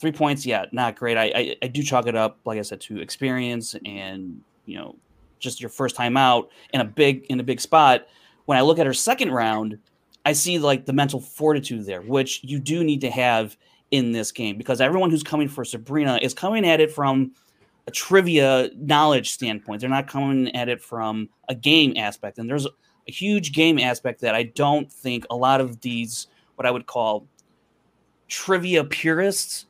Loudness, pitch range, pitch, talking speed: -22 LUFS, 120-150 Hz, 130 Hz, 200 wpm